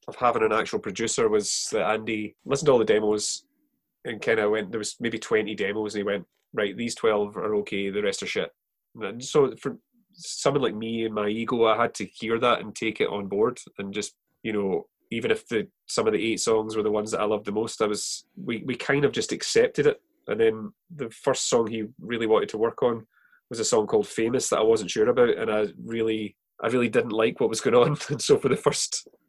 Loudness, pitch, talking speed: -25 LUFS, 125 Hz, 245 wpm